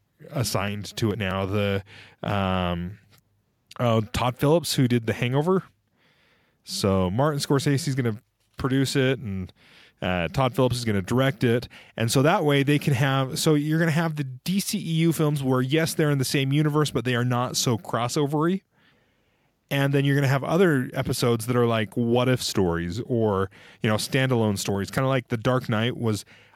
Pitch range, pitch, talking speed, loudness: 110-145 Hz, 125 Hz, 190 wpm, -24 LUFS